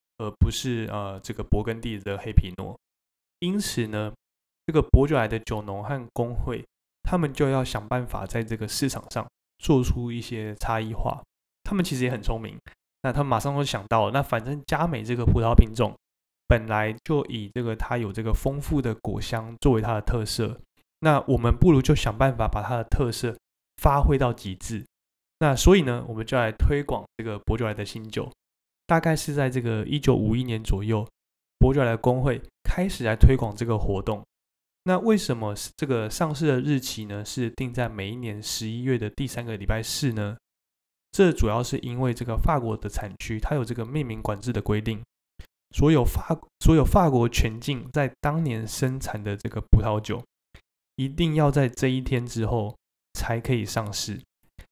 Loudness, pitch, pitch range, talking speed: -26 LUFS, 115 Hz, 105-130 Hz, 270 characters per minute